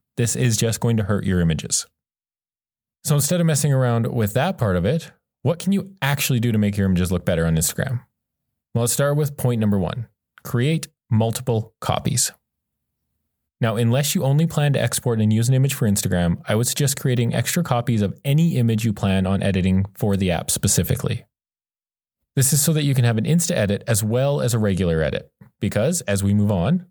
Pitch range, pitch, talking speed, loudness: 105-140 Hz, 120 Hz, 205 wpm, -20 LUFS